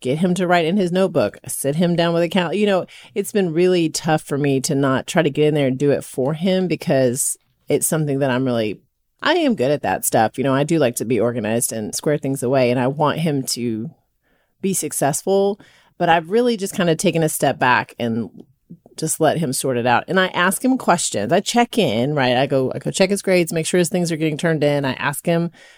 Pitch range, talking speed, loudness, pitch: 135-180 Hz, 250 wpm, -19 LUFS, 155 Hz